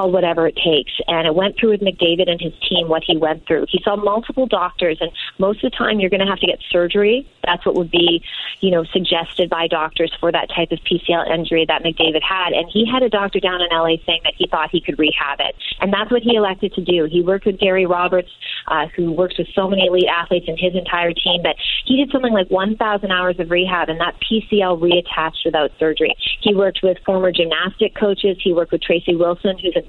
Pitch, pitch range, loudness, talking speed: 180 Hz, 170-195 Hz, -17 LUFS, 235 wpm